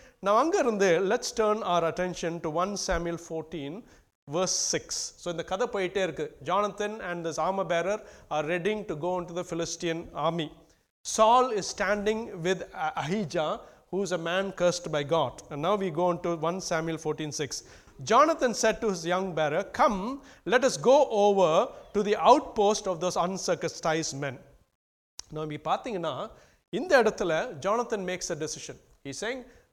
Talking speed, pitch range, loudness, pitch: 155 wpm, 165-210 Hz, -28 LUFS, 180 Hz